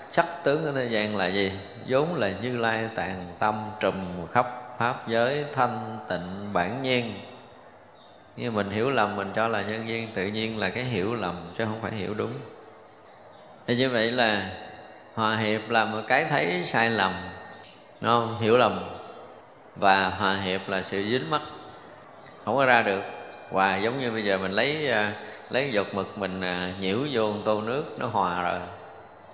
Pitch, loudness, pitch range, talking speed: 110 Hz, -26 LUFS, 95-120 Hz, 175 wpm